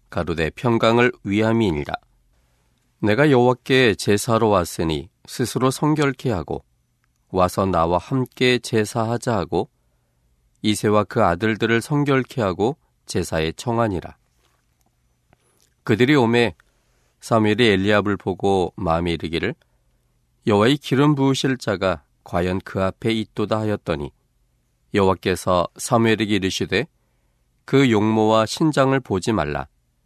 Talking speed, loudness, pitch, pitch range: 260 characters per minute, -20 LUFS, 105 Hz, 85-120 Hz